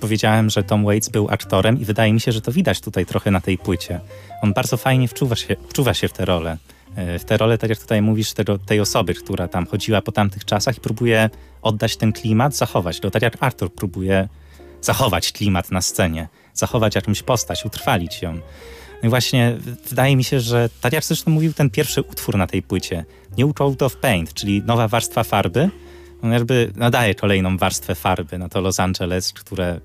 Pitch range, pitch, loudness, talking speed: 95-120 Hz, 105 Hz, -19 LUFS, 205 wpm